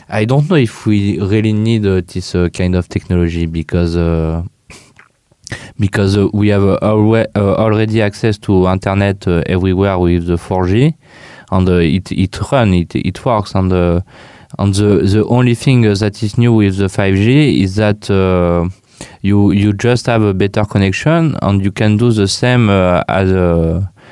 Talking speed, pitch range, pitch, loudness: 180 wpm, 90-110 Hz, 100 Hz, -13 LUFS